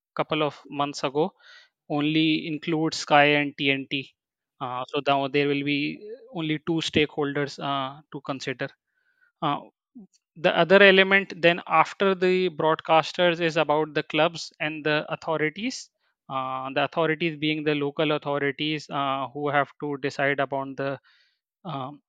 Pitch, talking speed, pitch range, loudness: 155 Hz, 140 wpm, 140-165 Hz, -24 LUFS